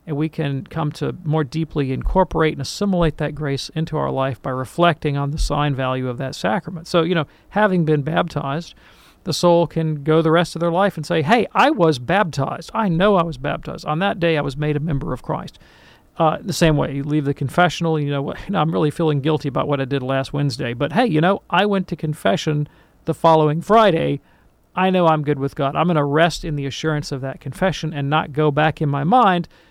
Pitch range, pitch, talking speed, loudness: 145-170 Hz, 155 Hz, 235 wpm, -19 LUFS